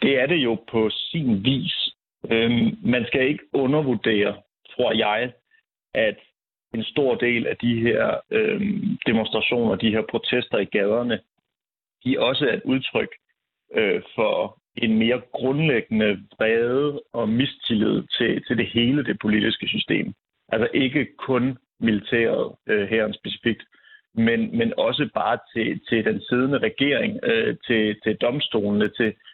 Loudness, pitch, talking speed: -22 LUFS, 120 Hz, 145 wpm